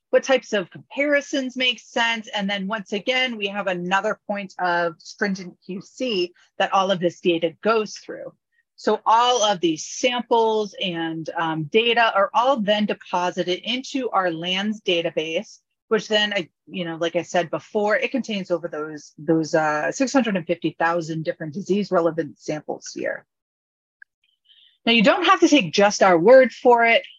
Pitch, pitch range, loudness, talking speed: 200 Hz, 175-230 Hz, -21 LUFS, 170 wpm